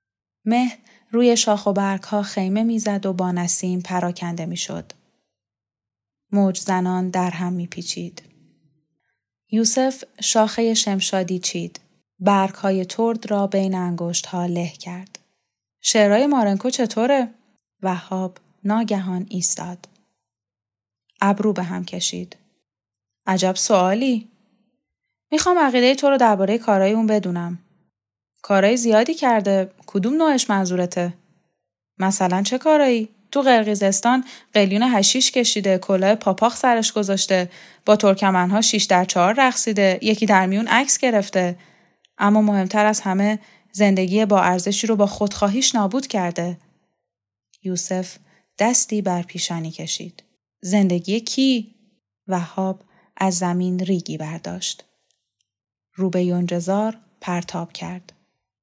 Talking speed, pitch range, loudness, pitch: 110 wpm, 180-215 Hz, -20 LUFS, 195 Hz